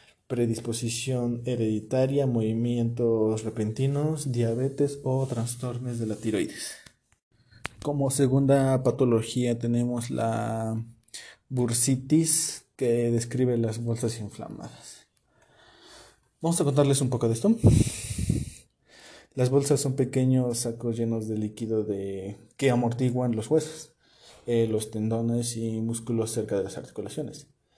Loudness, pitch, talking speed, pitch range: -27 LUFS, 120 Hz, 110 wpm, 115-130 Hz